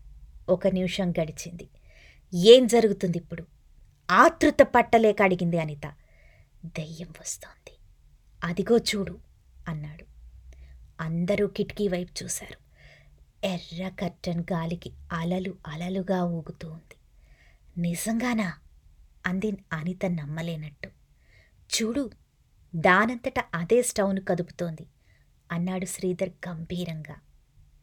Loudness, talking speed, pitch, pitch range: -26 LUFS, 80 wpm, 175 Hz, 160-195 Hz